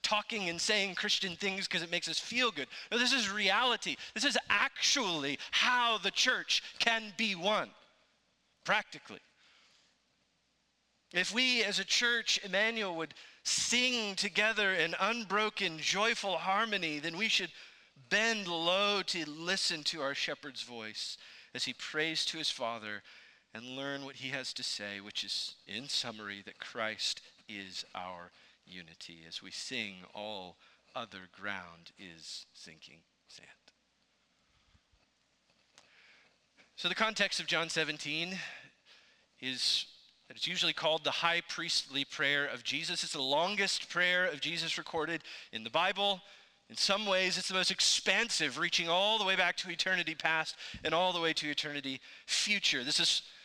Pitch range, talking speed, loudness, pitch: 140-200 Hz, 145 wpm, -32 LUFS, 170 Hz